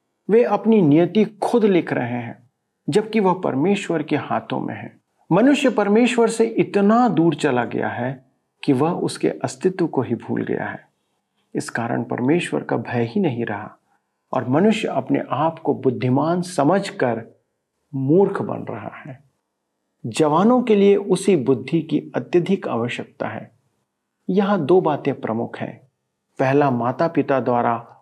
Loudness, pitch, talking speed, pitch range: -20 LUFS, 165 Hz, 145 wpm, 130-200 Hz